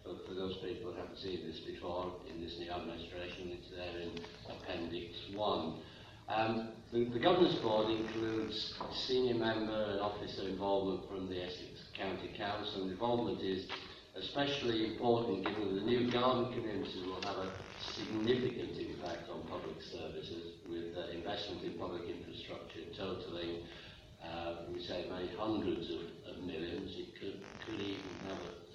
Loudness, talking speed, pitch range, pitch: -39 LUFS, 150 wpm, 85-110 Hz, 95 Hz